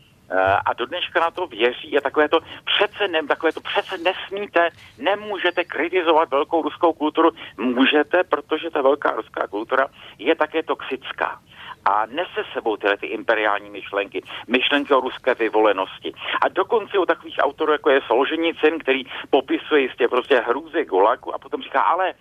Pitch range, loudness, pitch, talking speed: 145-185 Hz, -21 LUFS, 160 Hz, 155 wpm